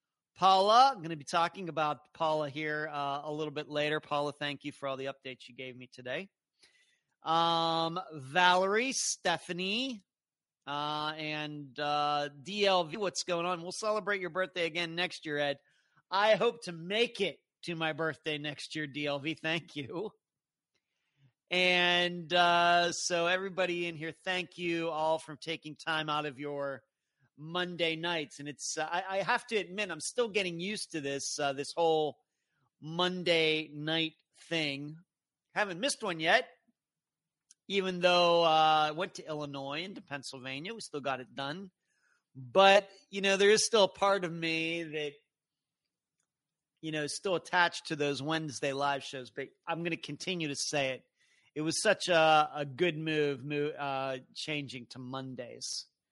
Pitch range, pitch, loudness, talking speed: 145-180 Hz, 160 Hz, -31 LUFS, 160 wpm